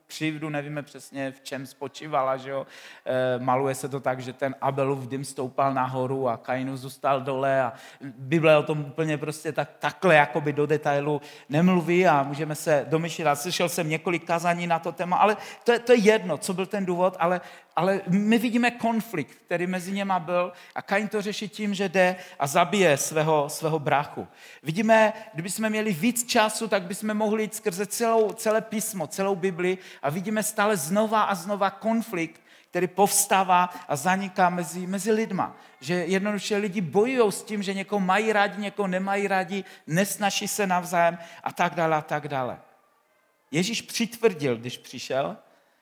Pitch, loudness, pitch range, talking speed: 180 Hz, -25 LUFS, 150-205 Hz, 175 wpm